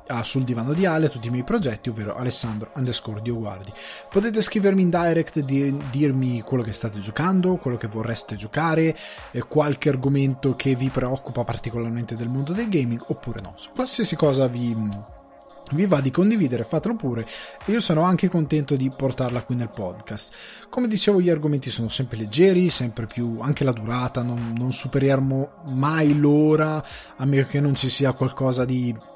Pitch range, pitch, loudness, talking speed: 120-155 Hz, 135 Hz, -23 LUFS, 170 wpm